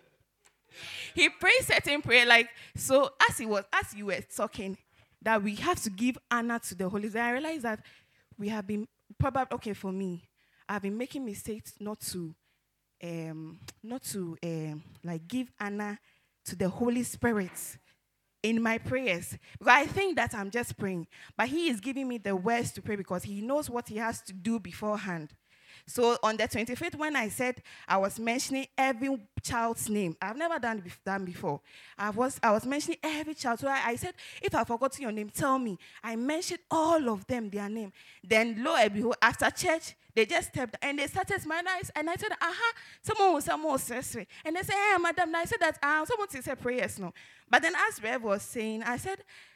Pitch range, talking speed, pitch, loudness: 205-290 Hz, 200 wpm, 235 Hz, -30 LUFS